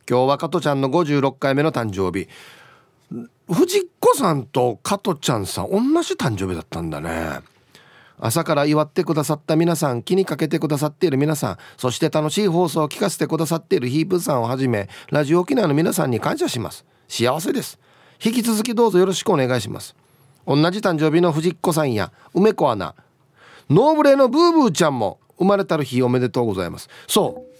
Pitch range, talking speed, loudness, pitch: 130-185 Hz, 390 characters per minute, -20 LUFS, 155 Hz